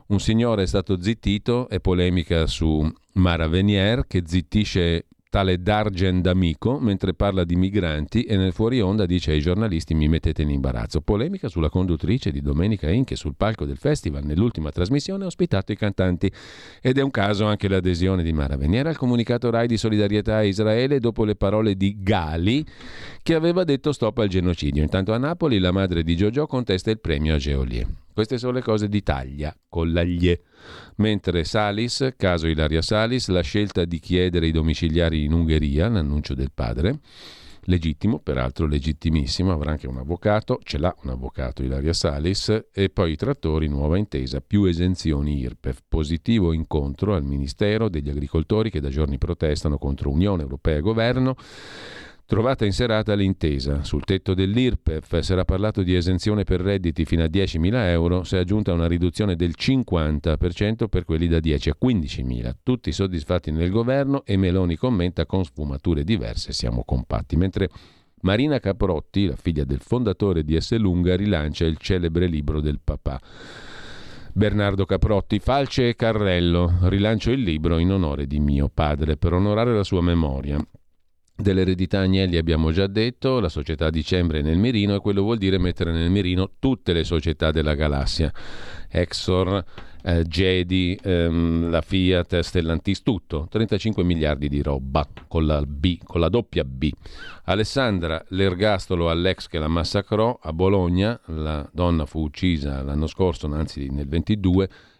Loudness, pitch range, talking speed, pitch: -22 LUFS, 80-105 Hz, 160 wpm, 90 Hz